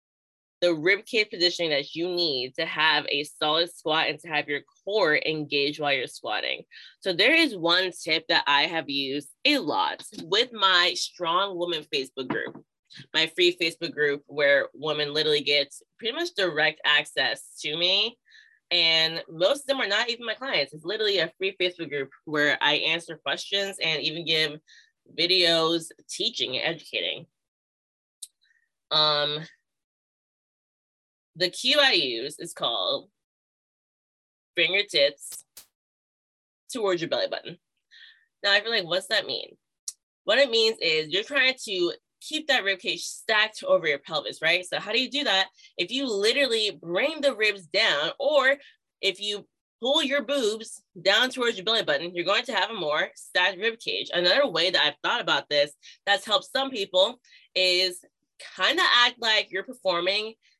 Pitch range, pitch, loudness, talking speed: 160-270 Hz, 190 Hz, -24 LUFS, 160 wpm